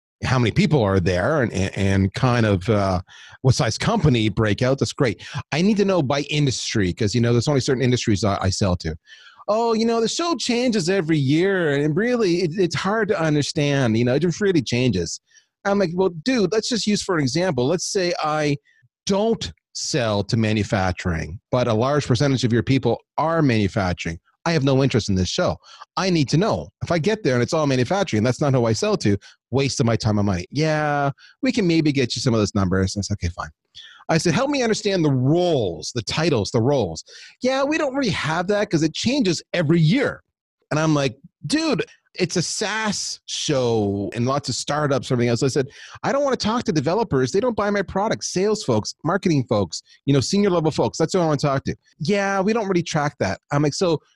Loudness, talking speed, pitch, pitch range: -21 LUFS, 225 wpm, 145 Hz, 120-190 Hz